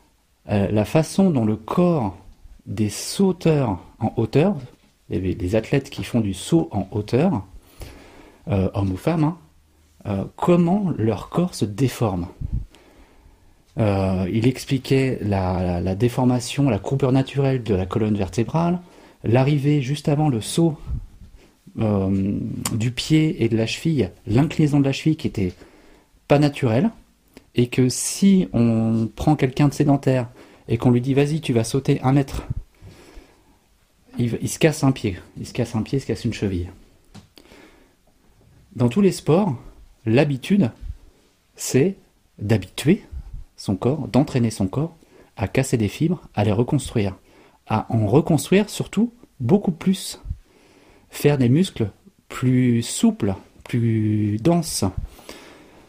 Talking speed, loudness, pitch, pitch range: 135 wpm, -21 LUFS, 120 Hz, 100-145 Hz